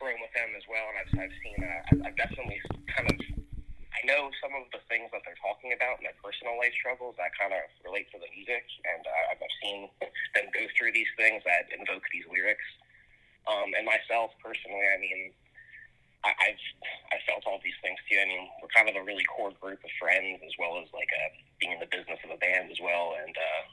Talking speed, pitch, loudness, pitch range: 225 wpm, 110 Hz, -30 LUFS, 95-125 Hz